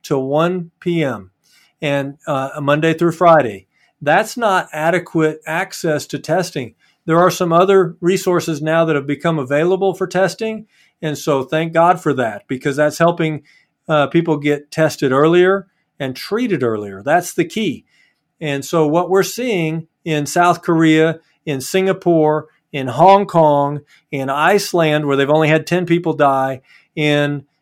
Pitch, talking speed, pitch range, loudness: 160 Hz, 150 wpm, 145-175 Hz, -16 LUFS